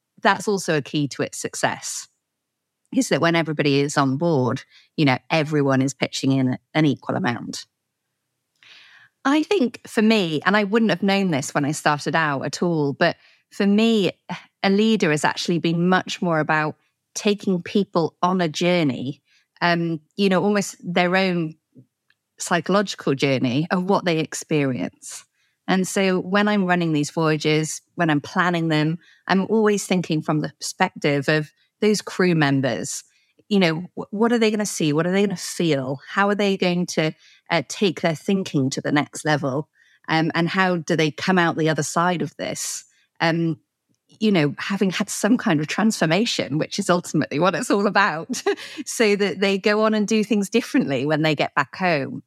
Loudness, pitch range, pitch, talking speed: -21 LUFS, 150-200 Hz, 170 Hz, 180 wpm